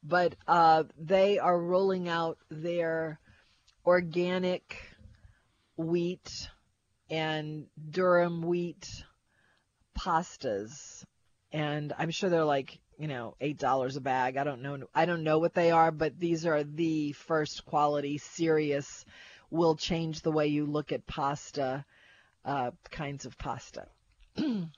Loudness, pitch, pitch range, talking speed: -30 LUFS, 155 Hz, 140-170 Hz, 125 wpm